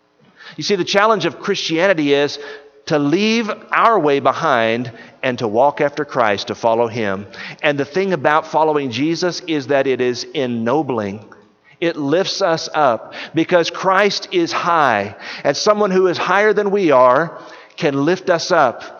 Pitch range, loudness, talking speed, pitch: 130-180 Hz, -17 LUFS, 160 wpm, 150 Hz